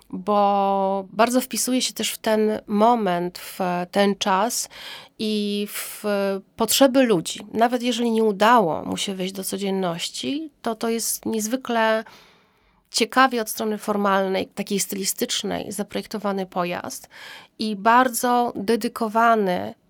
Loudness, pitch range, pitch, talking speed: -22 LUFS, 195-230 Hz, 220 Hz, 120 wpm